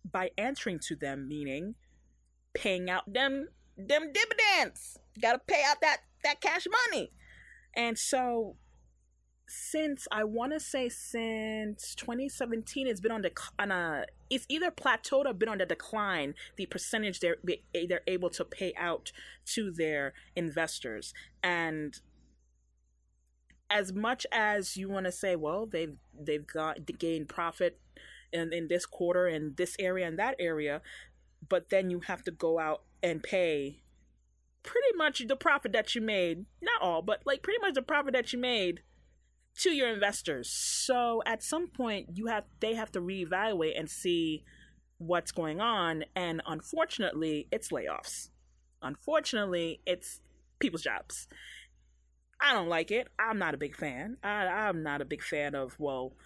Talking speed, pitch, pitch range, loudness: 160 wpm, 185 Hz, 155-235 Hz, -32 LUFS